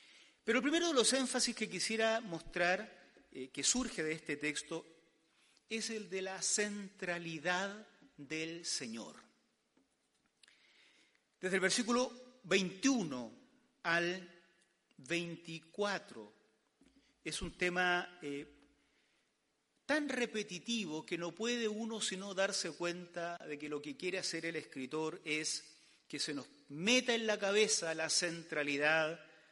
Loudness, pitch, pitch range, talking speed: -37 LUFS, 180 Hz, 160-220 Hz, 120 wpm